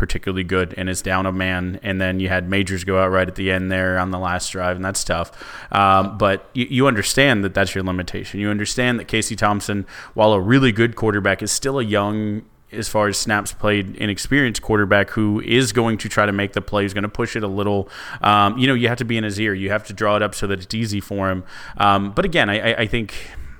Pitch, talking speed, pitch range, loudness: 100 Hz, 255 wpm, 95-110 Hz, -19 LUFS